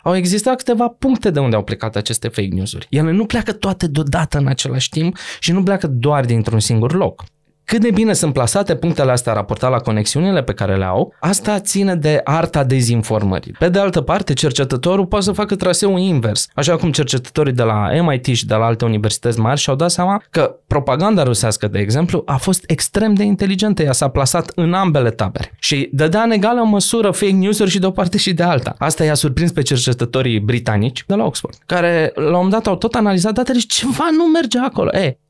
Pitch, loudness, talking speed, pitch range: 160 Hz, -16 LUFS, 210 wpm, 125-200 Hz